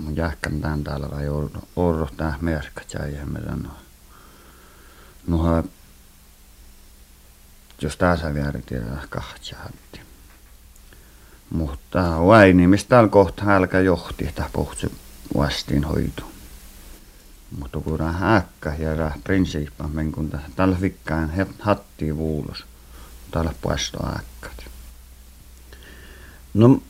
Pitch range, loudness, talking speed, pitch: 65-85 Hz, -22 LUFS, 110 wpm, 75 Hz